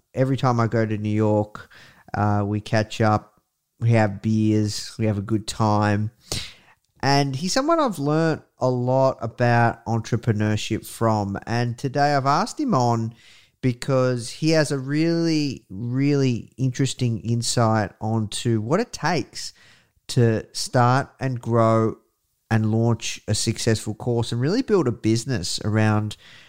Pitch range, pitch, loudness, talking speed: 110-135 Hz, 115 Hz, -22 LUFS, 140 wpm